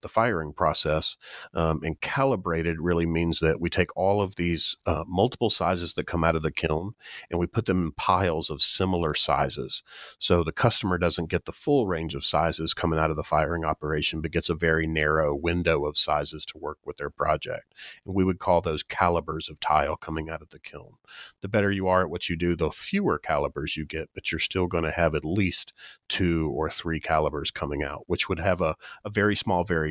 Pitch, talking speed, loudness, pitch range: 85 Hz, 220 wpm, -26 LUFS, 80-90 Hz